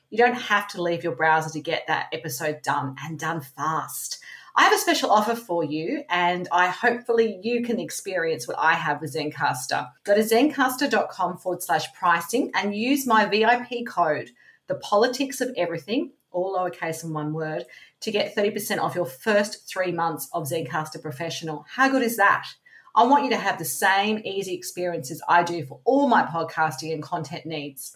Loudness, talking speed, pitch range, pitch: -24 LUFS, 185 wpm, 160-230 Hz, 180 Hz